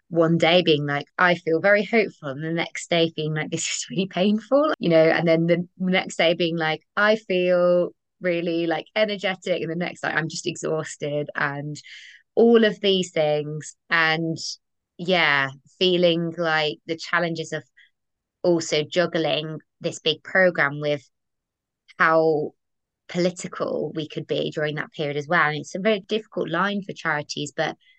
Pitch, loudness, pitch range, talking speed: 165 Hz, -22 LUFS, 155-180 Hz, 165 wpm